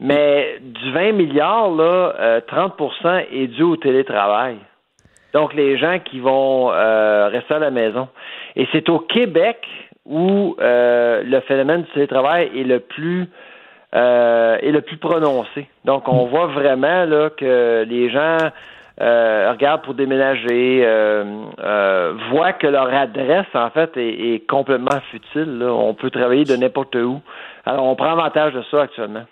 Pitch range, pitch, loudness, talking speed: 120-155 Hz, 135 Hz, -17 LUFS, 160 wpm